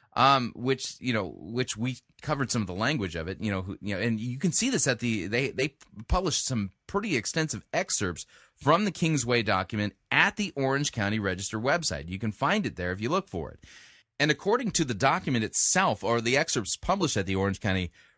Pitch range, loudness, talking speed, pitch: 105-150 Hz, -27 LUFS, 220 wpm, 120 Hz